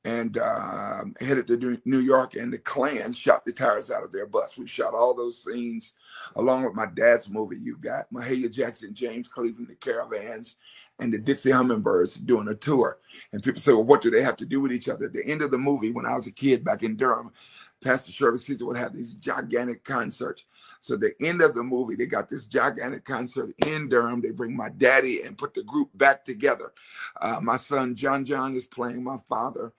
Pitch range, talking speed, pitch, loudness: 120-135 Hz, 220 wpm, 125 Hz, -26 LUFS